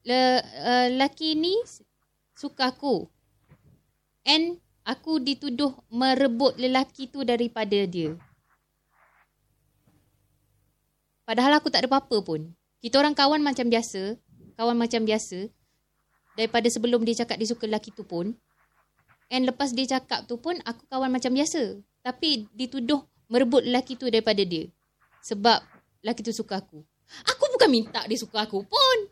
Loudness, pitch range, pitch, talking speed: -25 LUFS, 225-275 Hz, 245 Hz, 135 wpm